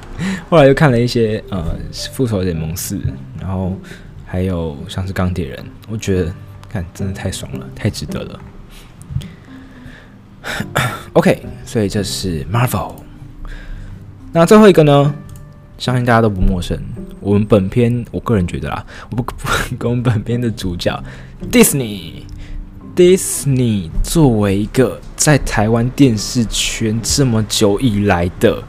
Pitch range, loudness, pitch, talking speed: 95-125 Hz, -15 LUFS, 105 Hz, 245 characters per minute